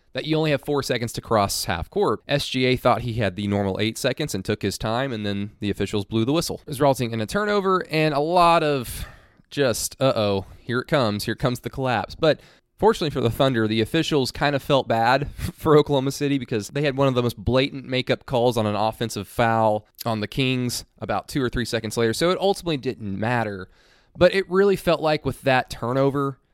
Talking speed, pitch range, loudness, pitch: 225 wpm, 110-145 Hz, -23 LUFS, 125 Hz